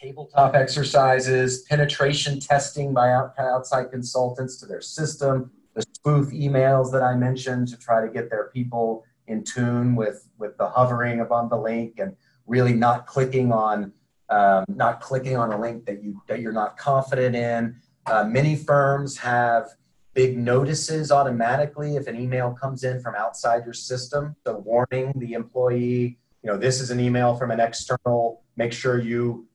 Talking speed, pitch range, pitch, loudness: 165 wpm, 120-135 Hz, 125 Hz, -23 LUFS